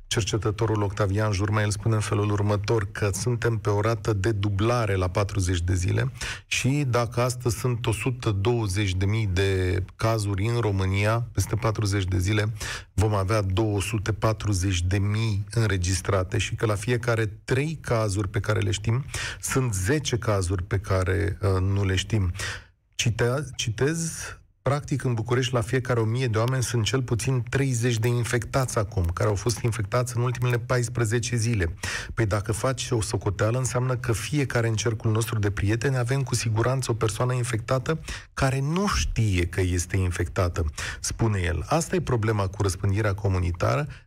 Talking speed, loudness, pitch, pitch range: 155 wpm, -25 LUFS, 110 Hz, 100-120 Hz